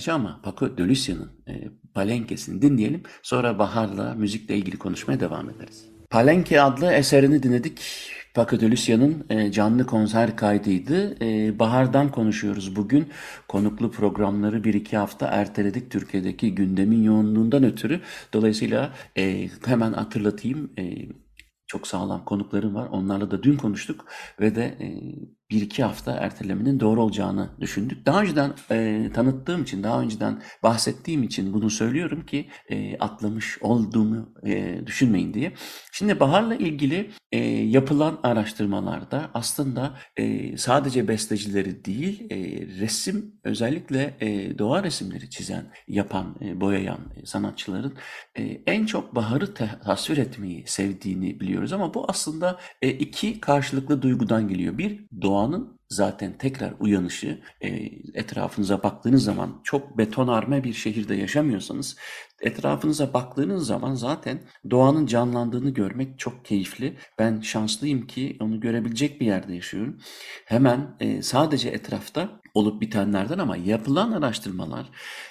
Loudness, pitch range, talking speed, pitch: -24 LUFS, 105-135 Hz, 125 wpm, 110 Hz